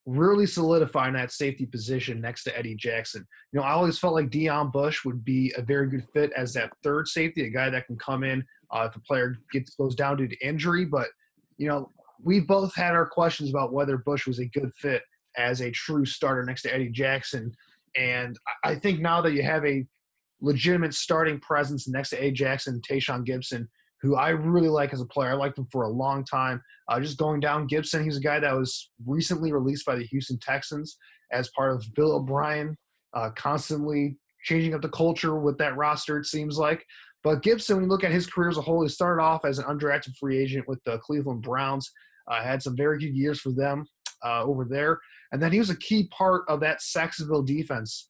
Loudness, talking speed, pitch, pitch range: -27 LUFS, 220 wpm, 145 Hz, 130-155 Hz